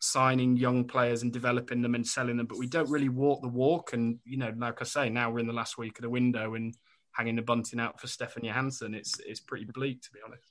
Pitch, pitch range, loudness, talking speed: 120 Hz, 115-130 Hz, -31 LUFS, 265 wpm